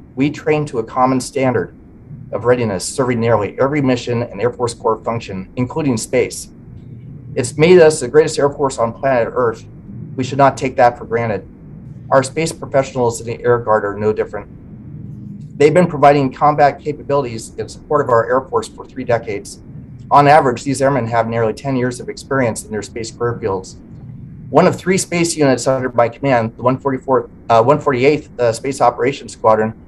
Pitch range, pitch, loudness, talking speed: 115-140 Hz, 130 Hz, -16 LUFS, 185 wpm